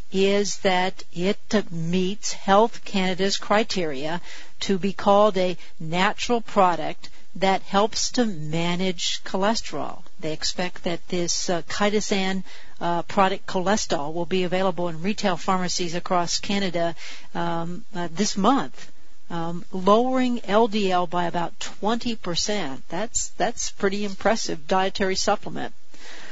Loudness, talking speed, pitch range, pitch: -24 LUFS, 115 wpm, 175-205 Hz, 190 Hz